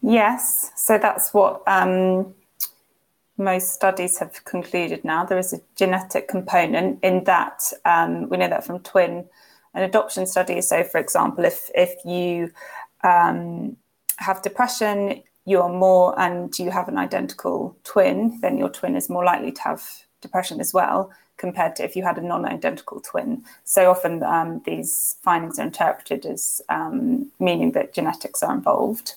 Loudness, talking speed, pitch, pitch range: -21 LUFS, 155 wpm, 190 Hz, 180-220 Hz